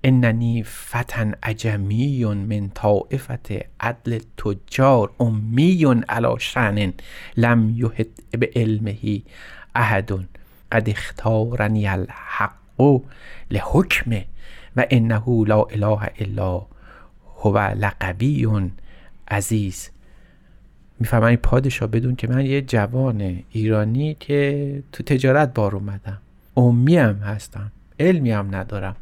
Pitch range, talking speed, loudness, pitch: 105-125 Hz, 95 wpm, -20 LUFS, 110 Hz